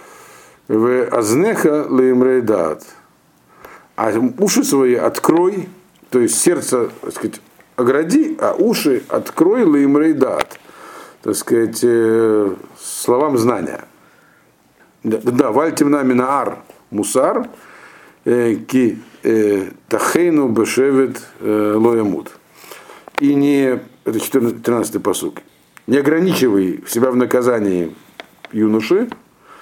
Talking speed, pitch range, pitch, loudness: 85 wpm, 115-150 Hz, 130 Hz, -16 LUFS